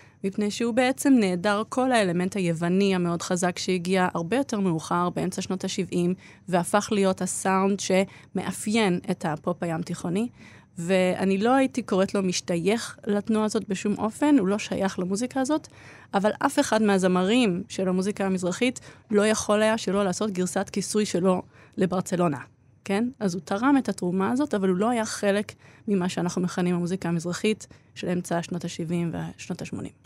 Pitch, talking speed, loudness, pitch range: 195 Hz, 155 wpm, -25 LUFS, 180-215 Hz